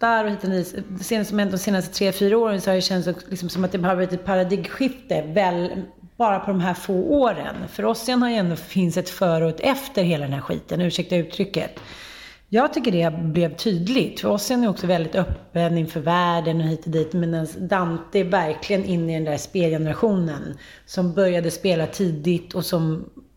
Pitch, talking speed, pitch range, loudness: 185 Hz, 195 wpm, 170-200 Hz, -22 LUFS